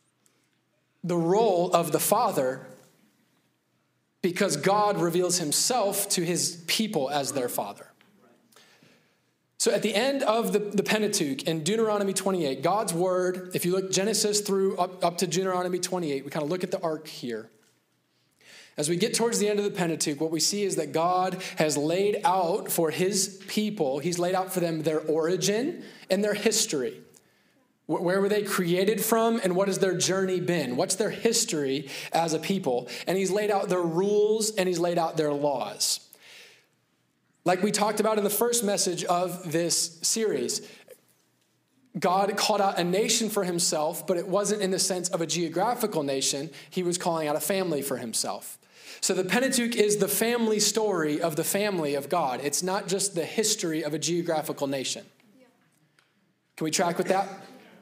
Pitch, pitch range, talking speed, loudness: 185 Hz, 165-205 Hz, 175 wpm, -26 LUFS